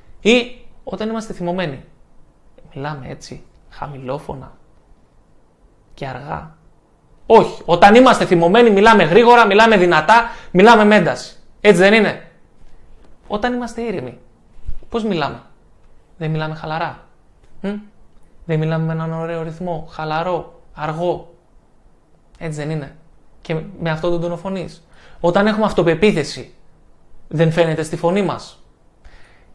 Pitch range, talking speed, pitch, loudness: 150-205 Hz, 110 wpm, 170 Hz, -15 LUFS